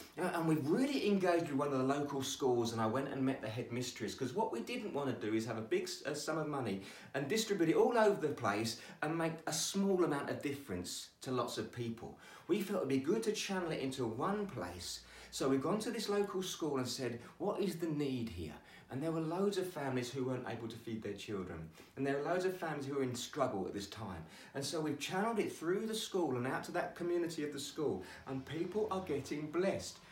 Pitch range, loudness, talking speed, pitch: 120-175 Hz, -38 LUFS, 245 wpm, 145 Hz